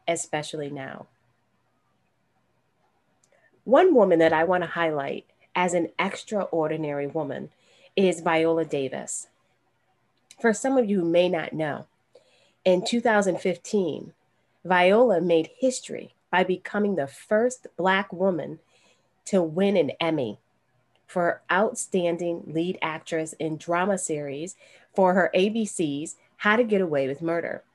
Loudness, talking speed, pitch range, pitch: -24 LUFS, 120 wpm, 160-195 Hz, 175 Hz